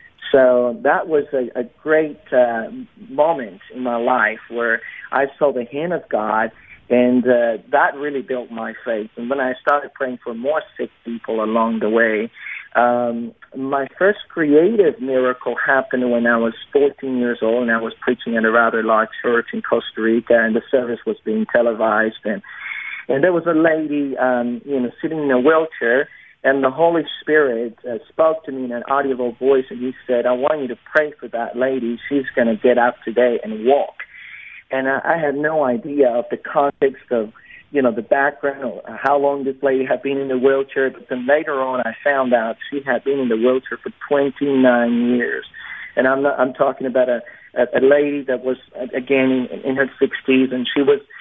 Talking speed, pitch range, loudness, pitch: 200 wpm, 120-140 Hz, -18 LUFS, 130 Hz